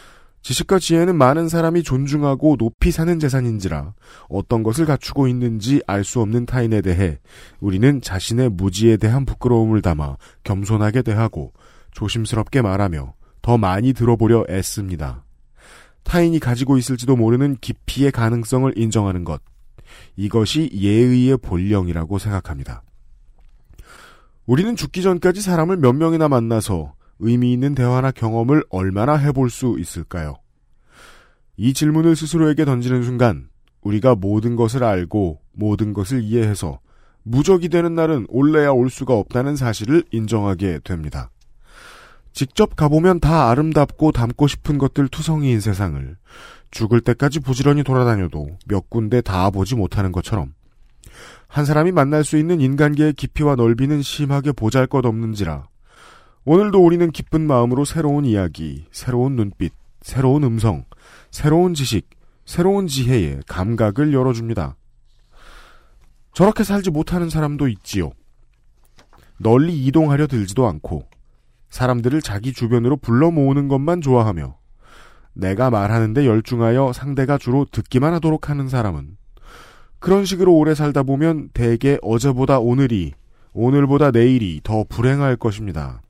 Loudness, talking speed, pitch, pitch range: -18 LUFS, 315 characters per minute, 125 Hz, 105-145 Hz